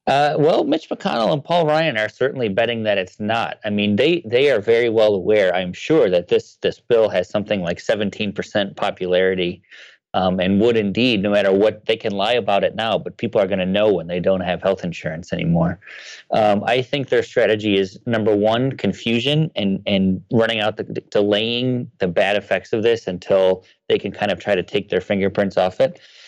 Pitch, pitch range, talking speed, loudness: 110 Hz, 95-135 Hz, 210 wpm, -19 LUFS